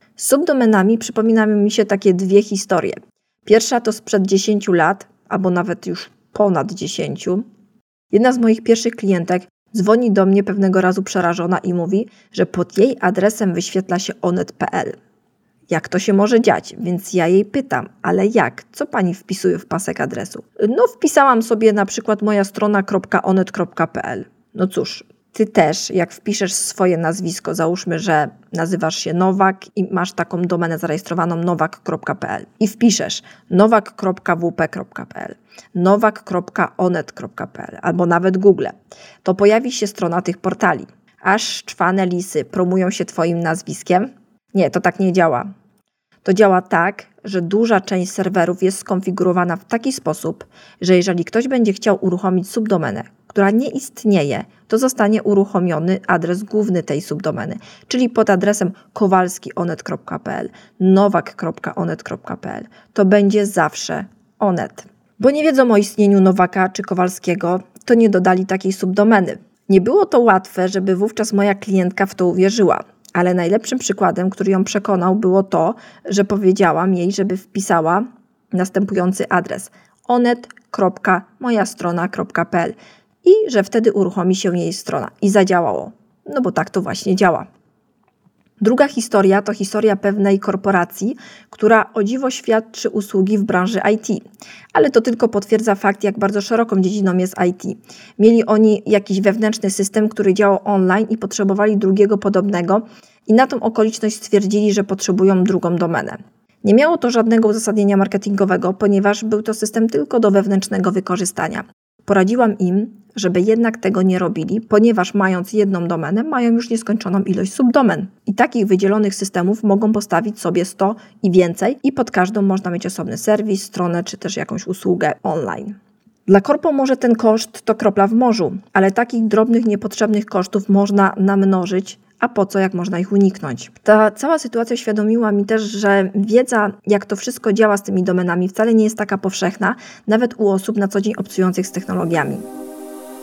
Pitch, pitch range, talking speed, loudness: 200 Hz, 185-215 Hz, 145 wpm, -17 LUFS